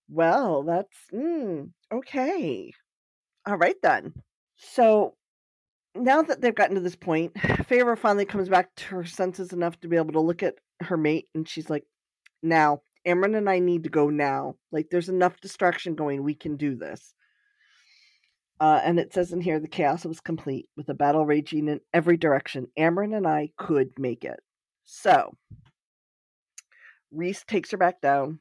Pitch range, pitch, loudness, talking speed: 155-190 Hz, 170 Hz, -25 LUFS, 170 wpm